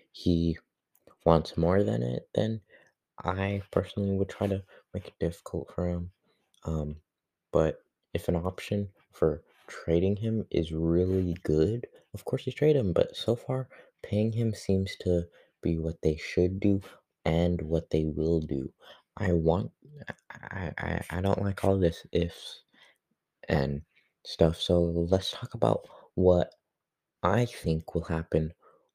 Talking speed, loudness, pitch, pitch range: 145 wpm, -29 LUFS, 85 Hz, 80-100 Hz